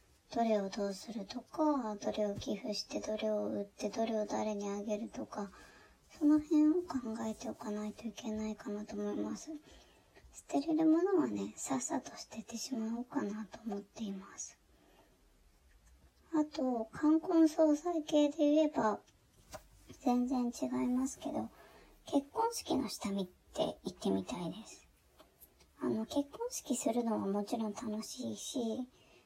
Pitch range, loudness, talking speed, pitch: 210-295 Hz, -36 LUFS, 275 characters per minute, 230 Hz